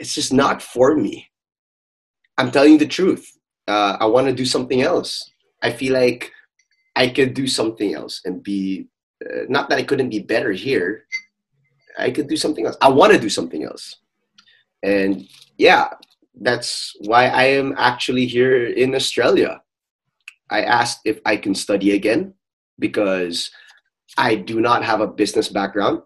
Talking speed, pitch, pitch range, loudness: 160 wpm, 130 Hz, 105-150 Hz, -18 LUFS